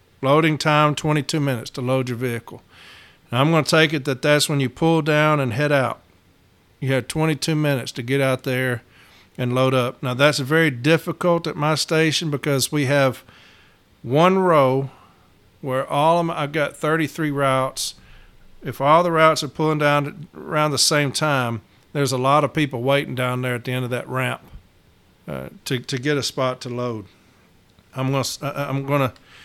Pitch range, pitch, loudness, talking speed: 125-150 Hz, 135 Hz, -20 LUFS, 190 wpm